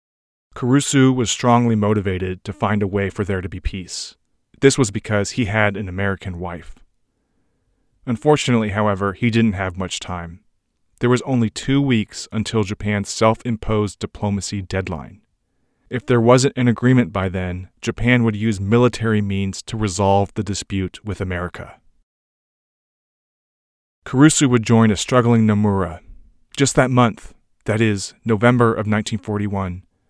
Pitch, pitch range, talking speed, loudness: 105 Hz, 95-120 Hz, 140 wpm, -19 LUFS